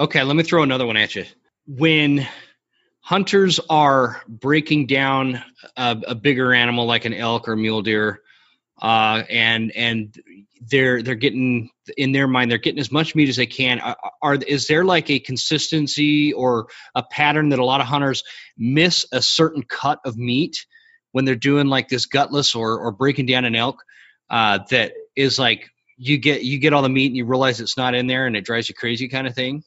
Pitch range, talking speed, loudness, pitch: 120-145 Hz, 200 wpm, -19 LUFS, 130 Hz